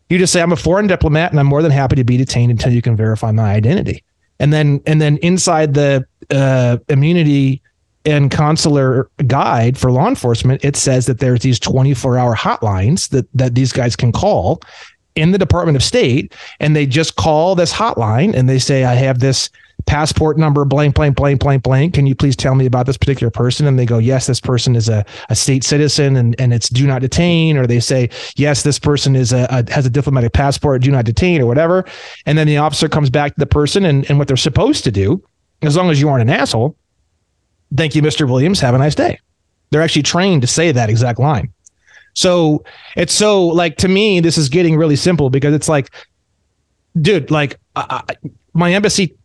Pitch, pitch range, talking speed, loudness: 140 Hz, 125-155 Hz, 215 wpm, -13 LUFS